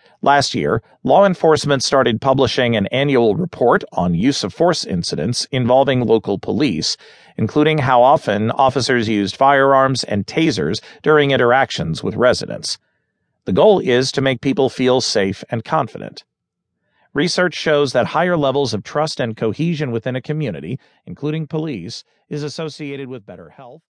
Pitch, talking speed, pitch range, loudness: 135 Hz, 145 wpm, 125-150 Hz, -17 LUFS